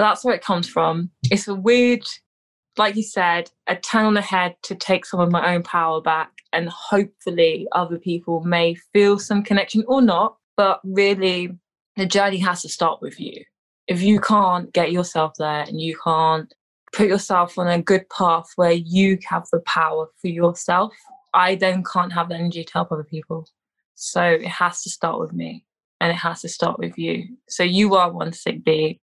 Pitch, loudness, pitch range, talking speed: 180 Hz, -20 LUFS, 170-200 Hz, 195 wpm